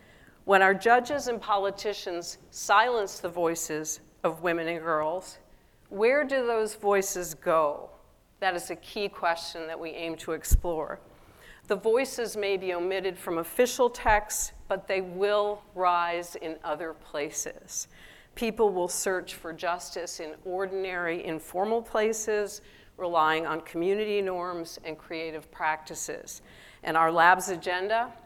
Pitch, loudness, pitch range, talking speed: 180 Hz, -28 LUFS, 165-210 Hz, 130 wpm